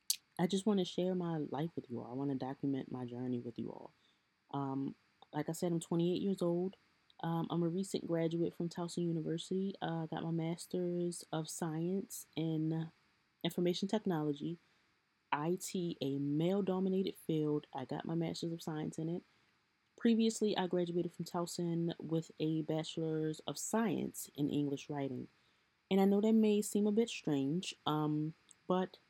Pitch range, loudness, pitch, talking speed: 150-180 Hz, -38 LUFS, 165 Hz, 165 wpm